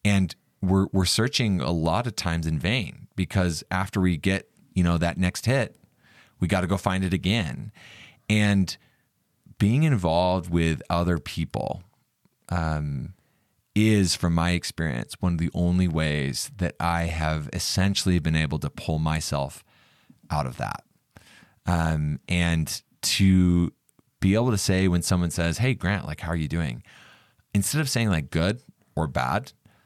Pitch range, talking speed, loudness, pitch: 80-100 Hz, 155 wpm, -25 LUFS, 90 Hz